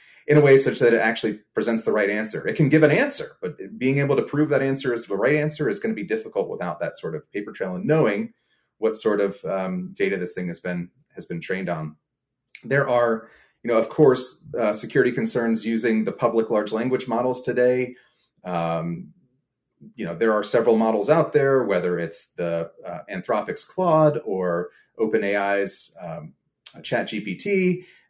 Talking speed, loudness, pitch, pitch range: 190 wpm, -23 LUFS, 120 Hz, 100-150 Hz